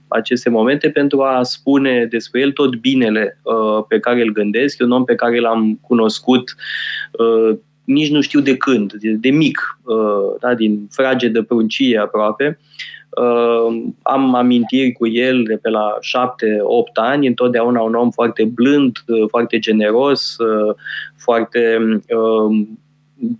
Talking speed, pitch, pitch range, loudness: 150 wpm, 120 Hz, 110-135 Hz, -15 LUFS